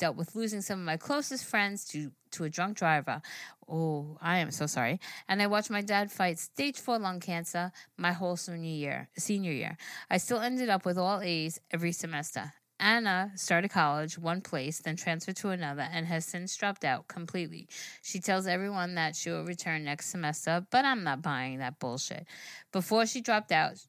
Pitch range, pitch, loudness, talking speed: 160-195 Hz, 175 Hz, -32 LUFS, 195 wpm